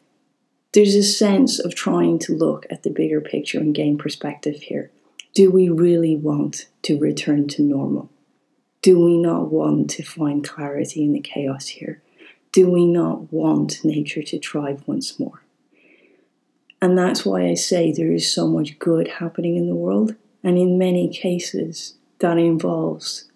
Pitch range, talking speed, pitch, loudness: 145-190 Hz, 160 wpm, 170 Hz, -19 LUFS